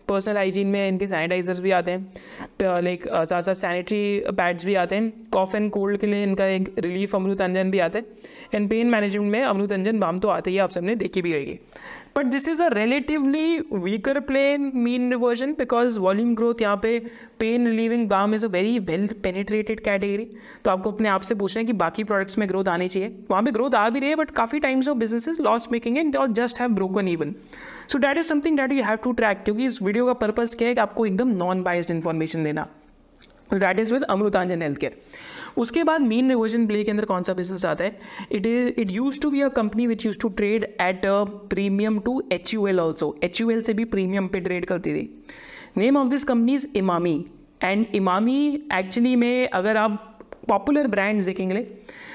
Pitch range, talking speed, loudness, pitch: 190-240 Hz, 220 wpm, -23 LUFS, 215 Hz